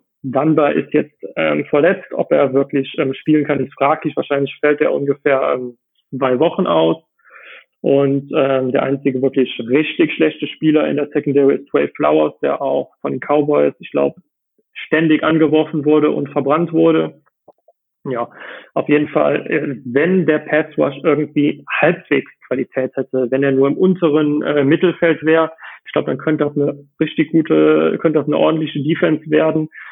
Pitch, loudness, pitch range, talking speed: 145 Hz, -16 LUFS, 135-155 Hz, 165 wpm